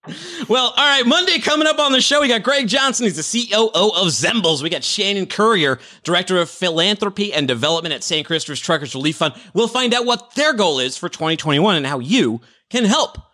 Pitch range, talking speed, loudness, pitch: 160-240 Hz, 210 wpm, -16 LUFS, 200 Hz